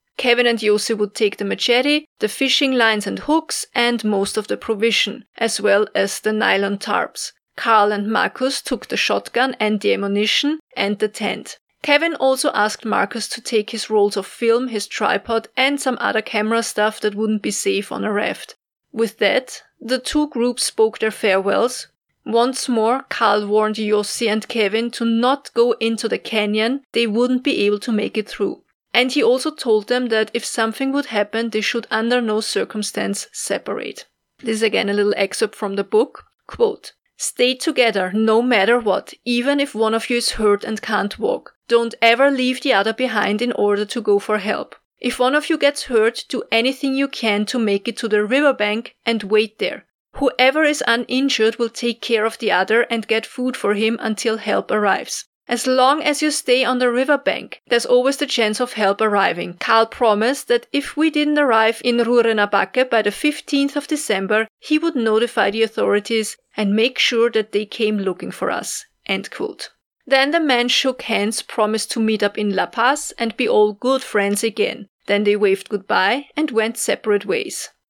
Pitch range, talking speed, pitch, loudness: 215-255 Hz, 190 wpm, 230 Hz, -19 LUFS